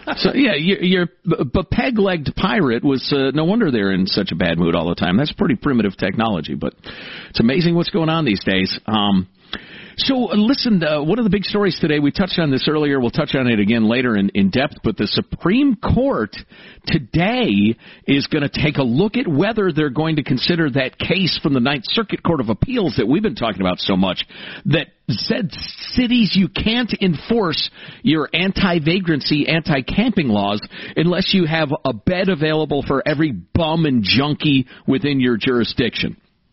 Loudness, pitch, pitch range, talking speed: -18 LUFS, 155 Hz, 130-190 Hz, 190 wpm